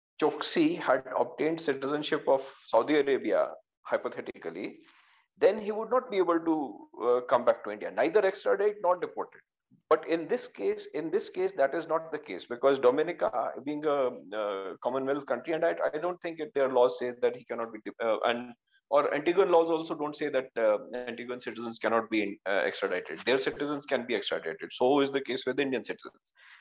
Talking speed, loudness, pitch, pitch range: 190 wpm, -30 LUFS, 155 Hz, 135-215 Hz